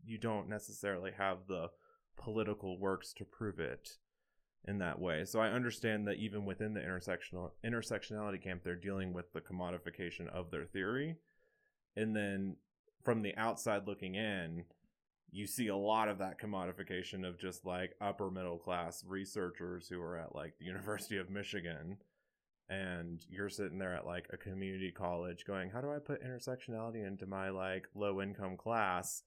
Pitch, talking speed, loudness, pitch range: 100 Hz, 165 wpm, -41 LUFS, 90-110 Hz